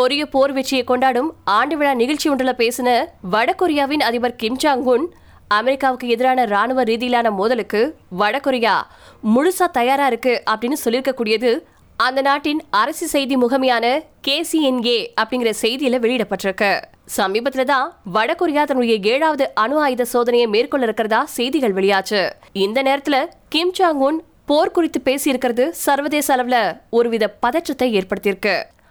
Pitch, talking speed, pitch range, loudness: 255 Hz, 110 wpm, 230-285 Hz, -18 LUFS